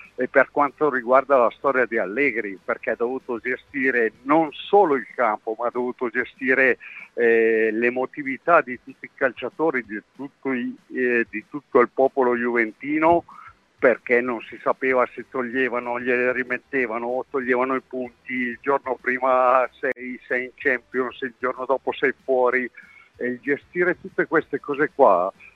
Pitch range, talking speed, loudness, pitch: 125-135 Hz, 155 wpm, -22 LUFS, 130 Hz